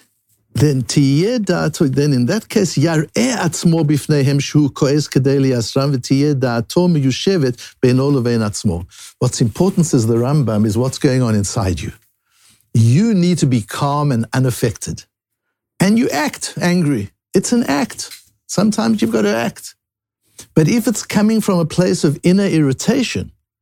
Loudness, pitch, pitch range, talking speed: -16 LUFS, 145 Hz, 125-175 Hz, 115 wpm